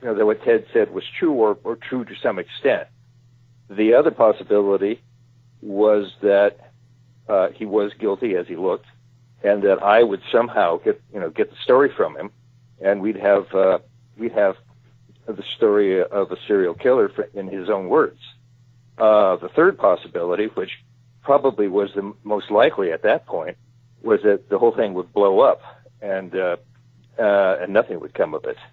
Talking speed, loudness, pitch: 180 wpm, -20 LUFS, 120 Hz